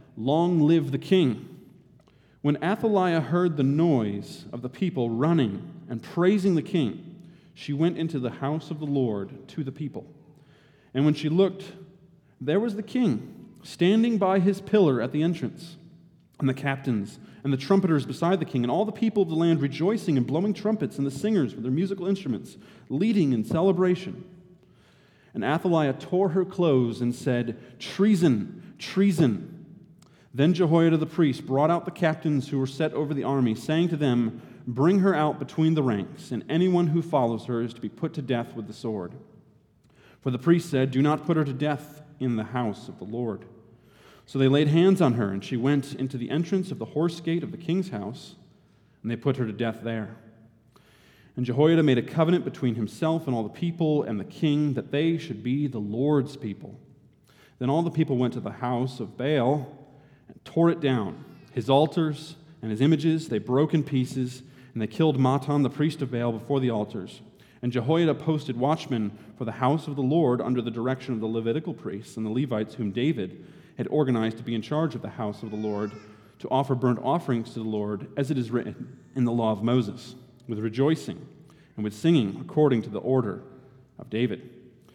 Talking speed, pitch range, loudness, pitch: 195 wpm, 125-165 Hz, -26 LUFS, 145 Hz